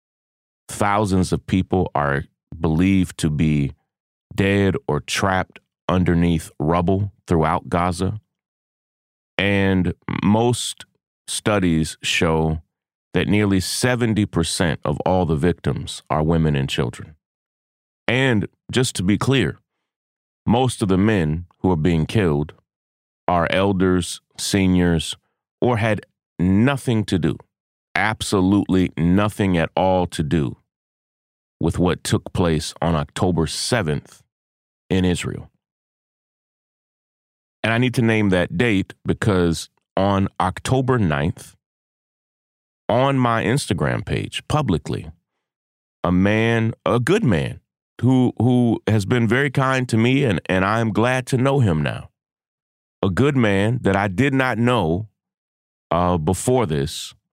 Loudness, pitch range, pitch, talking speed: -20 LUFS, 80-110 Hz, 95 Hz, 120 wpm